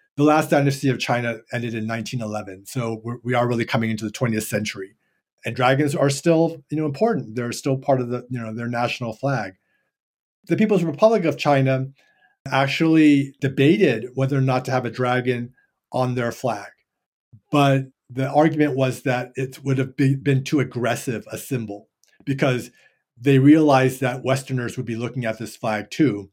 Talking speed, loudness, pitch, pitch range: 175 wpm, -21 LUFS, 130 Hz, 120-140 Hz